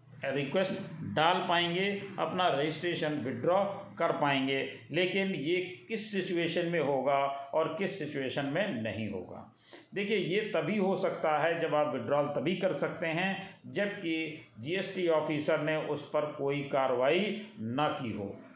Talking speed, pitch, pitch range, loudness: 140 wpm, 165 Hz, 145-190 Hz, -32 LUFS